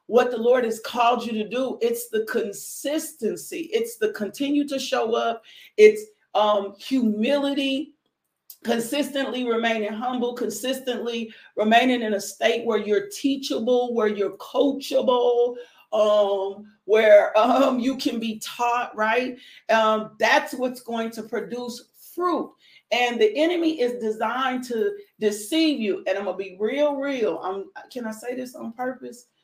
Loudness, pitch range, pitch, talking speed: -23 LUFS, 220-285 Hz, 245 Hz, 145 wpm